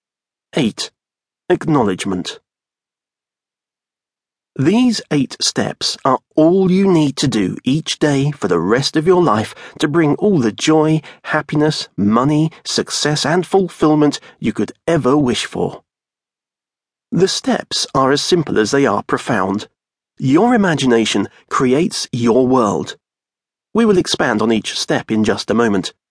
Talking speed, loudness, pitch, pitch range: 135 wpm, -16 LUFS, 155 Hz, 135-180 Hz